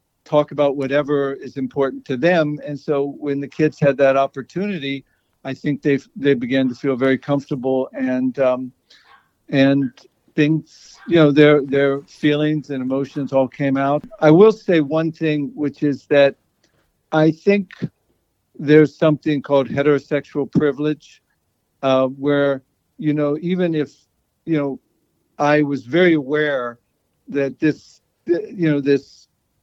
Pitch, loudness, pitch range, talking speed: 145 Hz, -18 LUFS, 135-150 Hz, 140 wpm